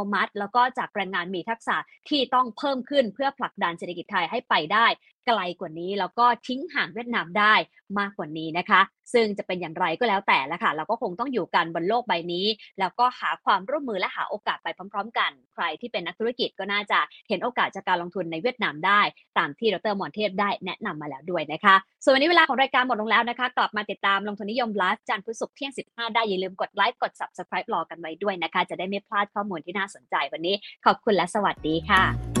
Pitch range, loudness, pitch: 185-240 Hz, -25 LUFS, 205 Hz